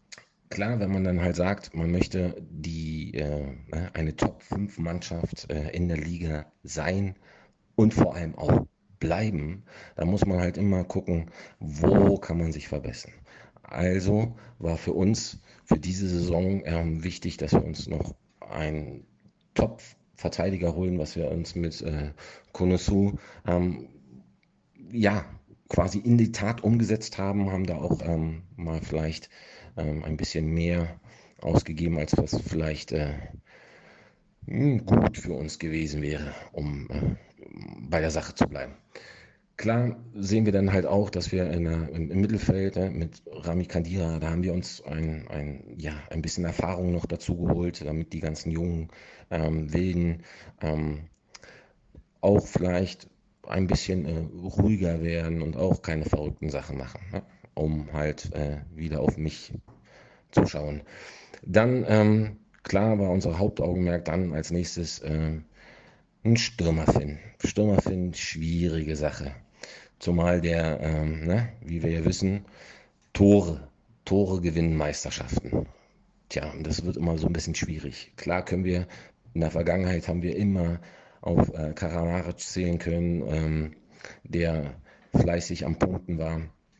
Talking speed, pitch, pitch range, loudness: 140 wpm, 85 Hz, 80-95 Hz, -28 LUFS